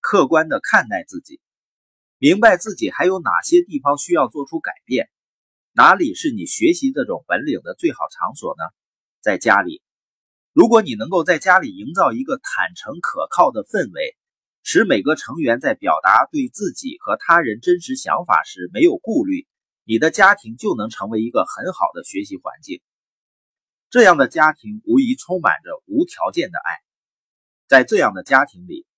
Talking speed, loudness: 255 characters per minute, -17 LUFS